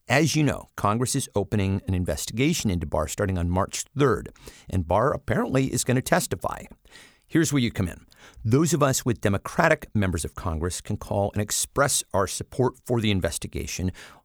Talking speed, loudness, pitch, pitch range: 180 wpm, -25 LUFS, 105 Hz, 90-130 Hz